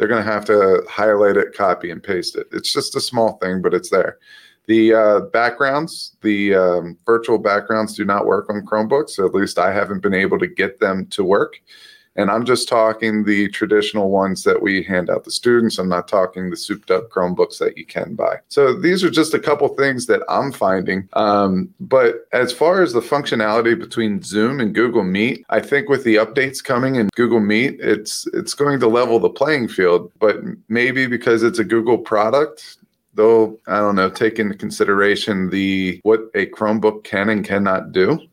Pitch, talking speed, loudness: 115 Hz, 200 wpm, -17 LUFS